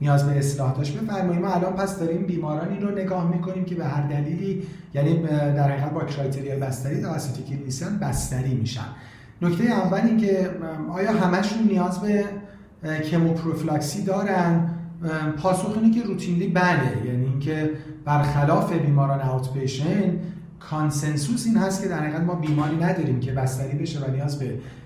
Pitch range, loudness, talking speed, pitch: 140-185 Hz, -24 LUFS, 145 wpm, 160 Hz